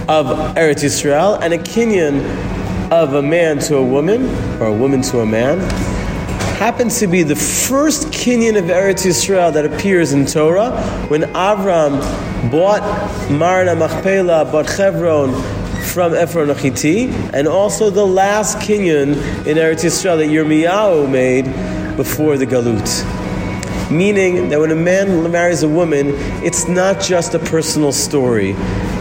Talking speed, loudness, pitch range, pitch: 140 wpm, -14 LUFS, 140-185 Hz, 160 Hz